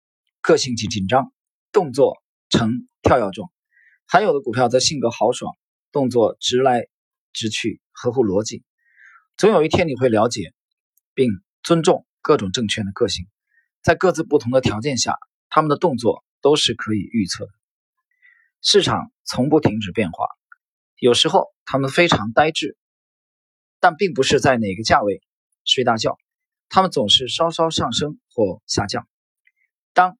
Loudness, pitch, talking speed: -19 LUFS, 165 Hz, 225 characters per minute